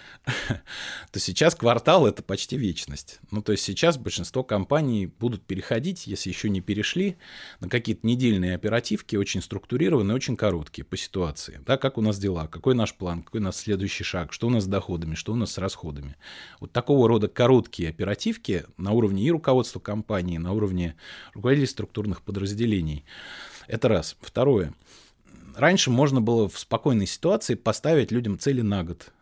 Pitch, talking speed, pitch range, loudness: 105 Hz, 165 wpm, 90-120 Hz, -25 LUFS